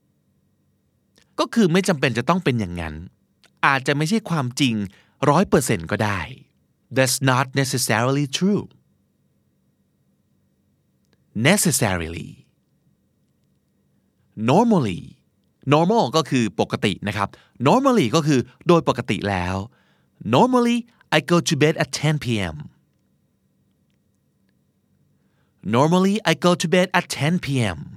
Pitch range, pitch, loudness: 115-175 Hz, 145 Hz, -20 LUFS